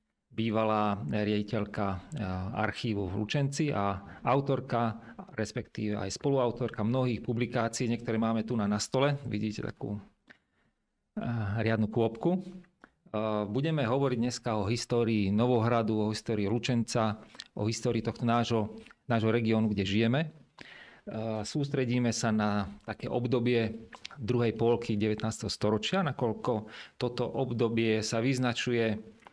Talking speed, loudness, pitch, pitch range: 105 wpm, -31 LUFS, 115 Hz, 110-125 Hz